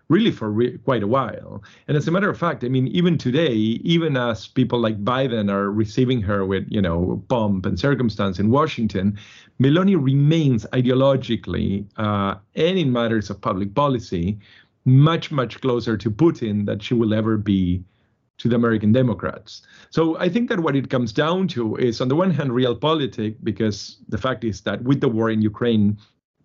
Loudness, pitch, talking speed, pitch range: -21 LUFS, 120 Hz, 185 wpm, 105-135 Hz